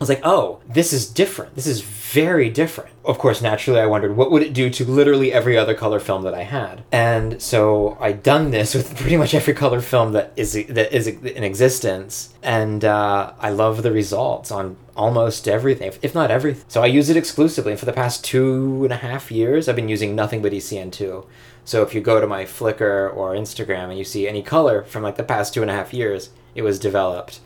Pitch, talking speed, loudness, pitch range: 115 Hz, 225 wpm, -19 LUFS, 105-135 Hz